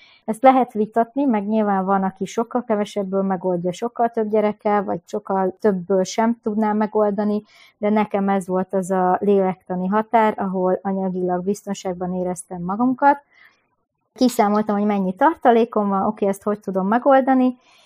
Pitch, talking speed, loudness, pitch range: 210 Hz, 140 wpm, -20 LUFS, 190-230 Hz